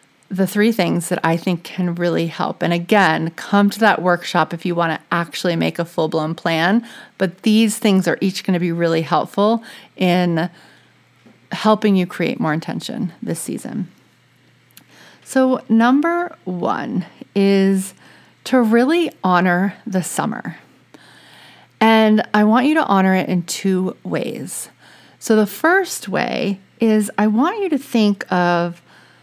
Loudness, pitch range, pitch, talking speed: -18 LUFS, 175-225 Hz, 195 Hz, 150 wpm